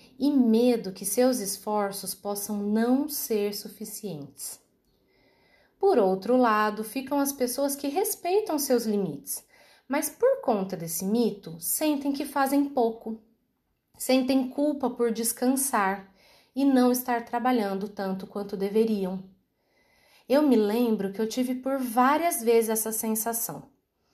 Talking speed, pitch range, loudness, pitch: 125 wpm, 205-270 Hz, -26 LUFS, 230 Hz